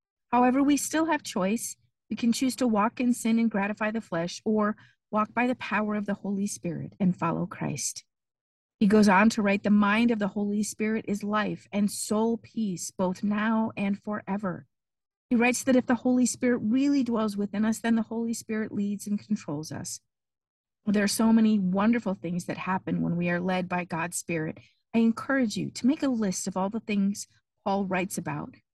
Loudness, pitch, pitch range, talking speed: -27 LUFS, 210 Hz, 190-230 Hz, 200 wpm